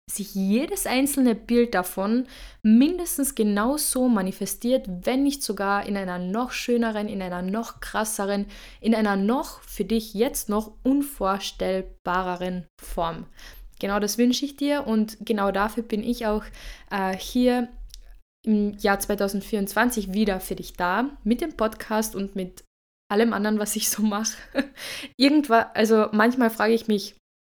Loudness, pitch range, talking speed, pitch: -24 LUFS, 200-245 Hz, 140 wpm, 215 Hz